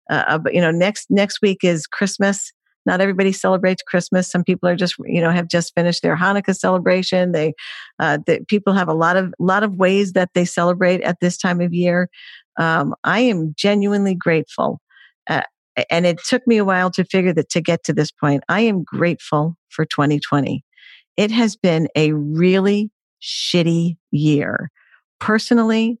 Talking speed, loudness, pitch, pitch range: 175 wpm, -18 LUFS, 180 Hz, 165-200 Hz